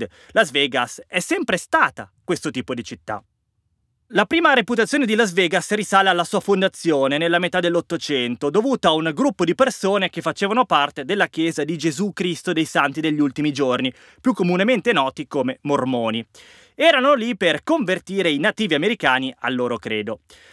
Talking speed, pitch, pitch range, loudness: 165 wpm, 175 Hz, 145-210 Hz, -20 LUFS